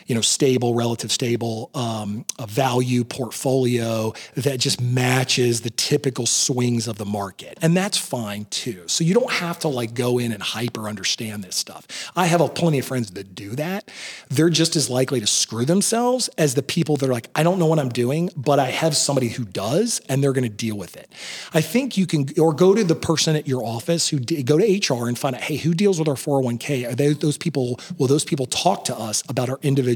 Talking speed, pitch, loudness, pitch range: 230 wpm, 135 Hz, -21 LUFS, 120-160 Hz